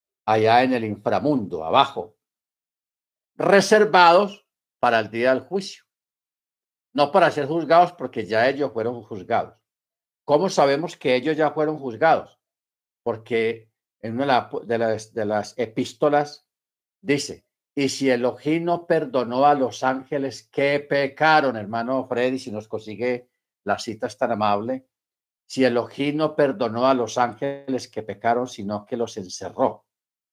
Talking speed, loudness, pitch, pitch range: 130 wpm, -22 LUFS, 130 Hz, 115-150 Hz